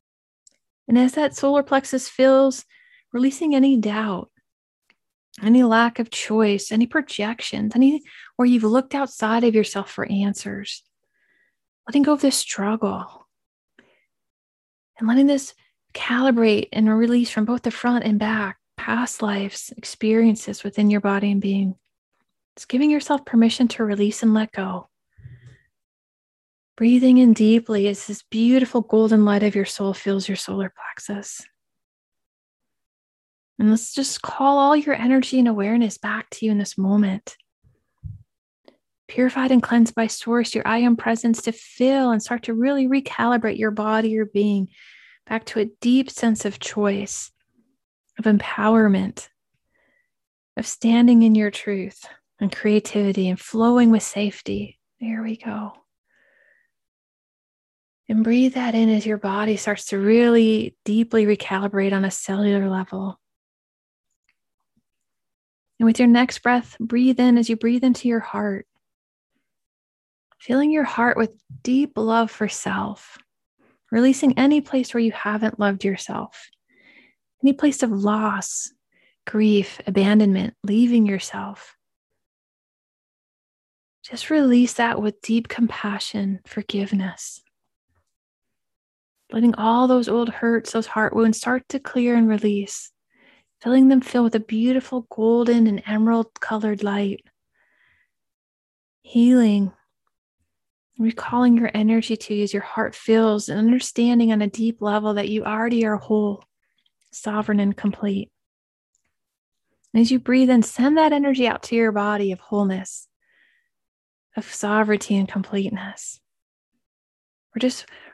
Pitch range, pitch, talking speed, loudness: 205-245 Hz, 225 Hz, 130 wpm, -20 LUFS